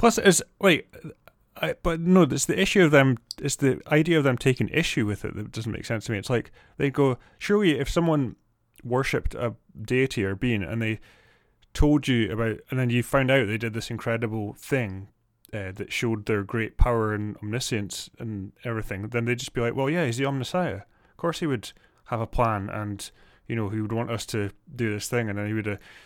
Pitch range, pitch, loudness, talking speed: 110-135 Hz, 115 Hz, -26 LUFS, 220 wpm